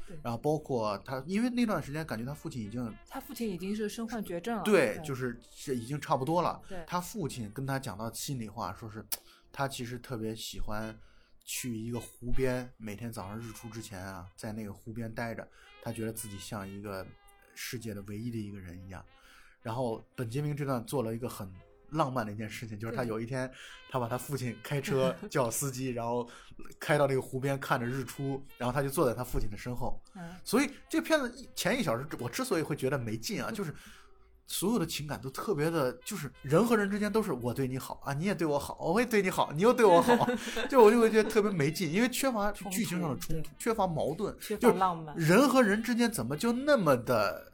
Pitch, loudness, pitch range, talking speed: 135 Hz, -32 LUFS, 115-190 Hz, 320 characters per minute